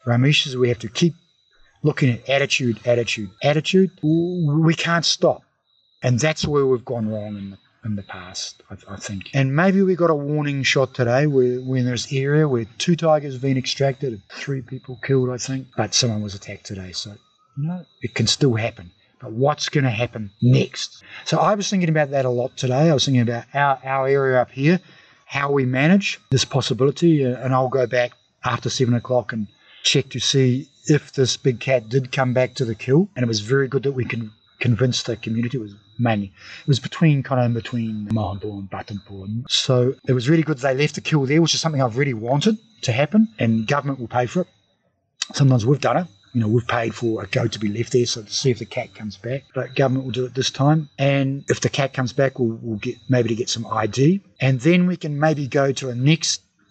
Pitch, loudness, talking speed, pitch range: 130 Hz, -20 LUFS, 230 wpm, 120-145 Hz